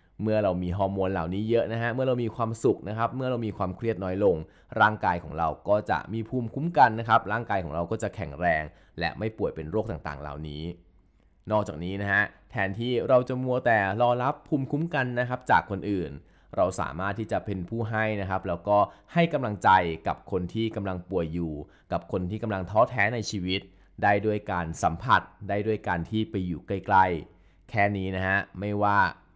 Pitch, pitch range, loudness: 100 Hz, 95-115 Hz, -27 LUFS